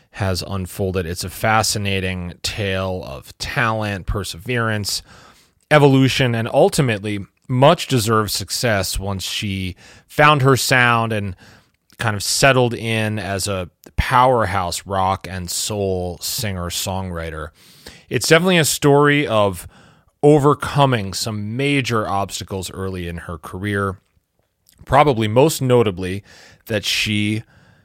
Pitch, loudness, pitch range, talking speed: 105 Hz, -18 LUFS, 95-120 Hz, 110 wpm